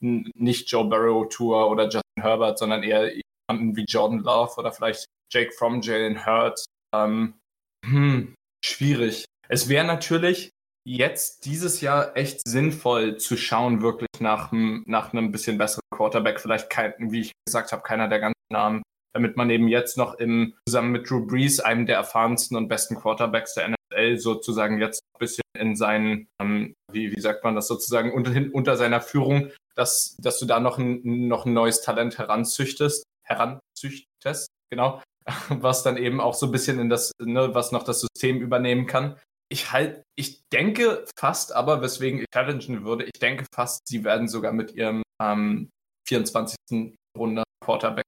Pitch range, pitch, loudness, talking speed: 110-130 Hz, 115 Hz, -24 LUFS, 170 wpm